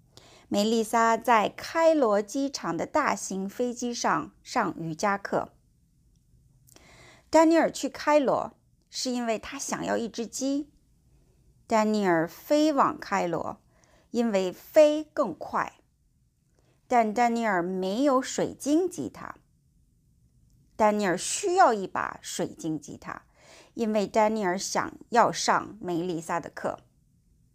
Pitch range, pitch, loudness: 195-275 Hz, 230 Hz, -26 LUFS